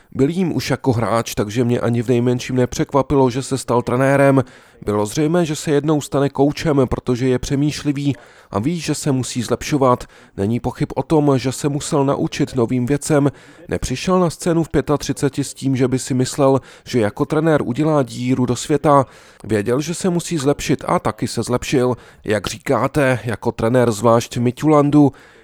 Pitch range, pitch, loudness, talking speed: 125-145 Hz, 135 Hz, -18 LUFS, 175 wpm